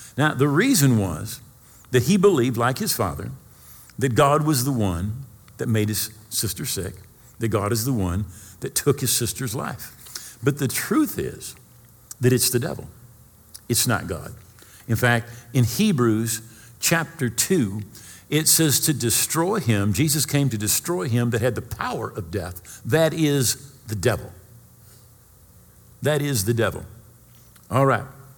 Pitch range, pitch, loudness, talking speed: 110-135 Hz, 120 Hz, -22 LUFS, 155 wpm